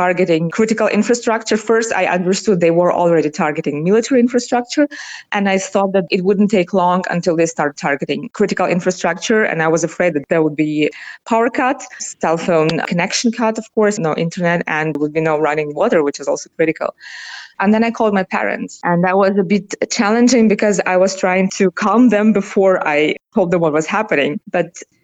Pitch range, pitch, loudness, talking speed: 170-215 Hz, 190 Hz, -16 LUFS, 195 wpm